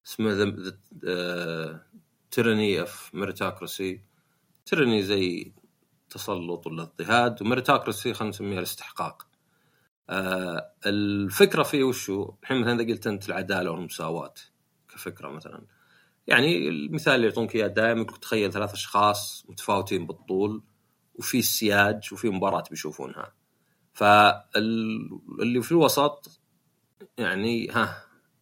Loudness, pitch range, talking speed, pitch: -25 LUFS, 95-115 Hz, 95 wpm, 105 Hz